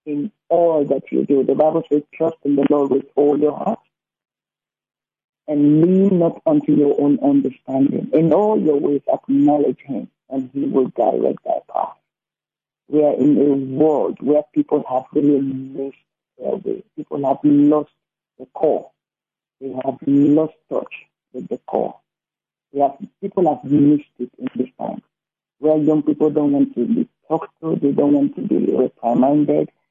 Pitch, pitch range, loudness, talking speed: 145 Hz, 135-155 Hz, -18 LUFS, 165 wpm